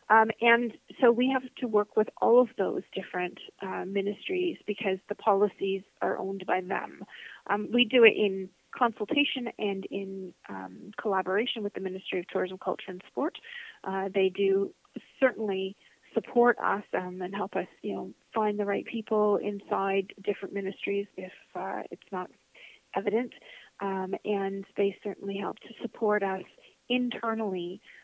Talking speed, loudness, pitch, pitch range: 155 wpm, -29 LUFS, 200 Hz, 190-225 Hz